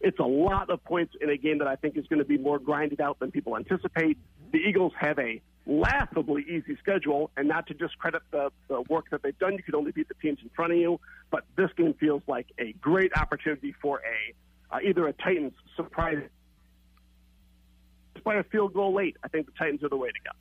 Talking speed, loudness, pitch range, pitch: 225 wpm, -29 LUFS, 140-175 Hz, 150 Hz